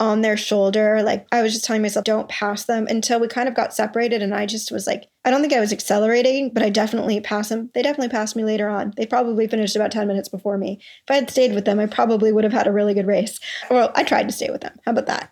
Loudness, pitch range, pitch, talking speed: -20 LUFS, 210-230 Hz, 215 Hz, 285 wpm